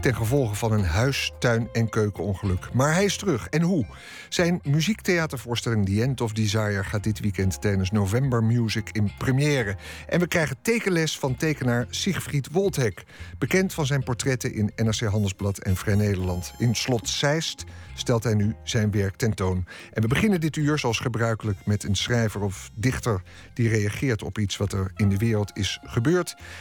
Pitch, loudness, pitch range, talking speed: 115 Hz, -25 LUFS, 100-135 Hz, 175 wpm